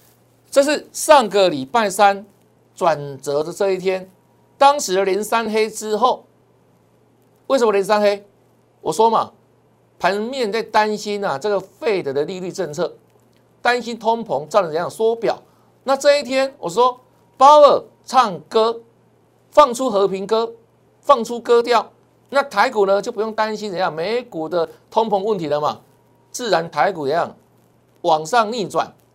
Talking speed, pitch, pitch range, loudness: 215 characters per minute, 215 Hz, 190-240 Hz, -18 LUFS